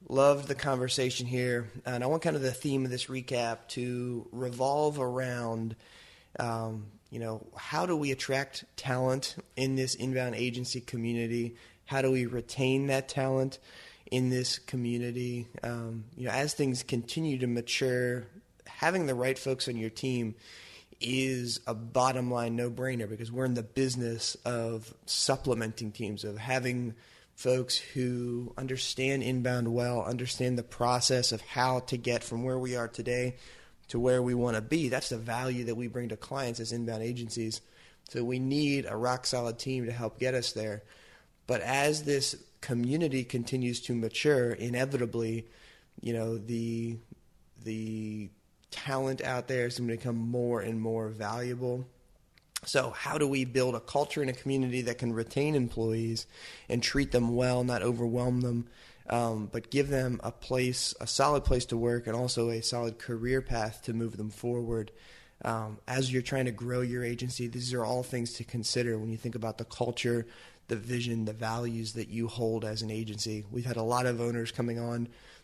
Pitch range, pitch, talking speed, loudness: 115-130 Hz, 120 Hz, 175 wpm, -32 LUFS